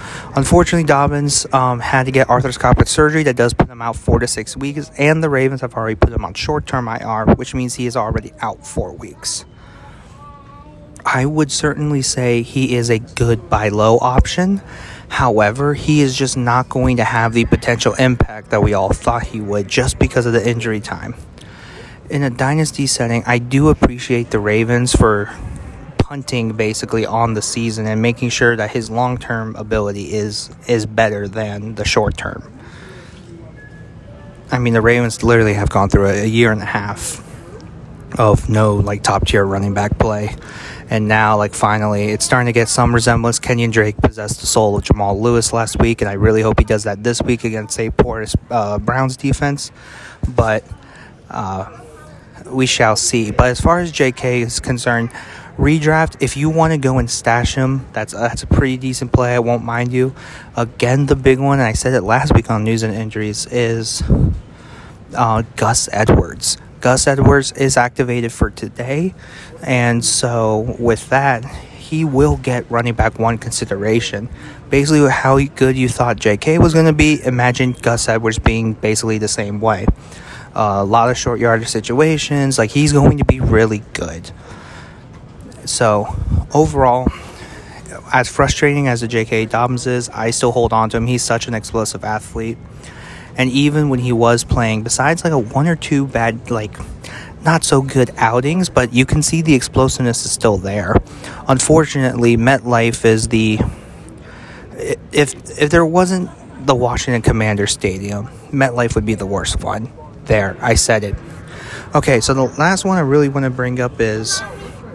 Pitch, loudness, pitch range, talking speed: 120 Hz, -15 LUFS, 110-135 Hz, 175 wpm